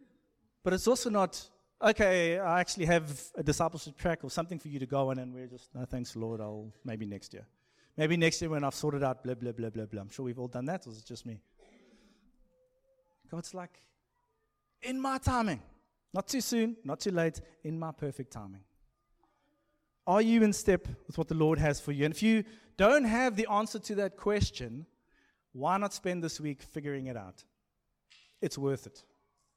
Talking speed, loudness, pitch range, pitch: 200 wpm, -32 LUFS, 125-205 Hz, 160 Hz